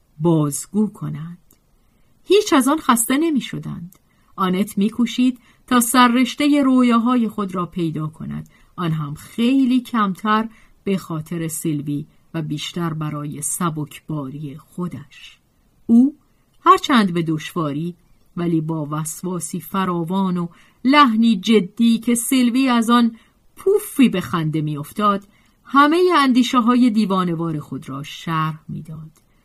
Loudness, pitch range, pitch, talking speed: -19 LUFS, 160-245 Hz, 190 Hz, 120 wpm